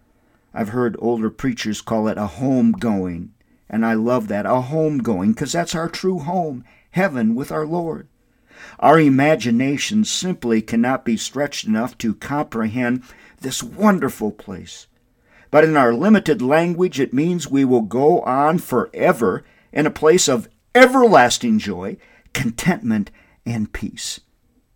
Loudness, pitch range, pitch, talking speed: -18 LUFS, 120-180 Hz, 140 Hz, 140 wpm